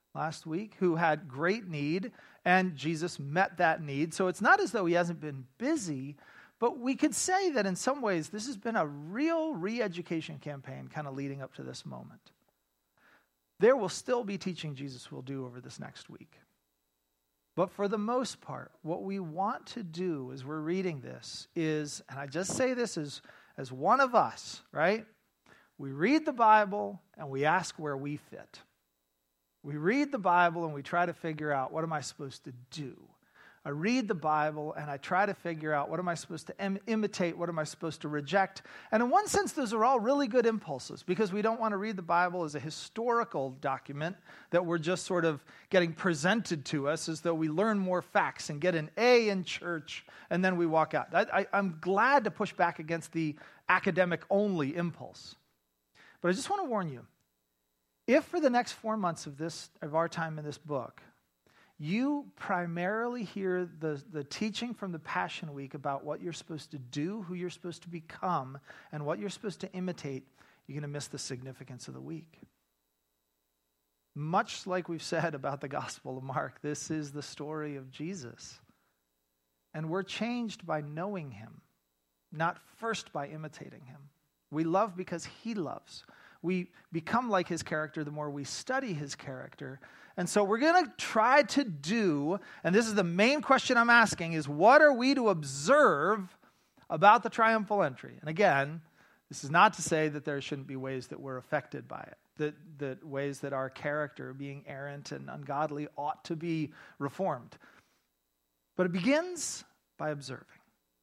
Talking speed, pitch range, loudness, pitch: 190 wpm, 145-195 Hz, -31 LUFS, 165 Hz